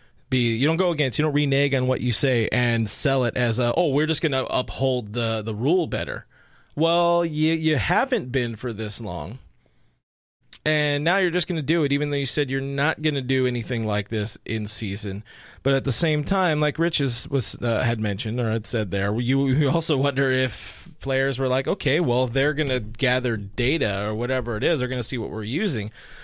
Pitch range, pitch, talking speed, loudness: 115-145 Hz, 130 Hz, 225 wpm, -23 LUFS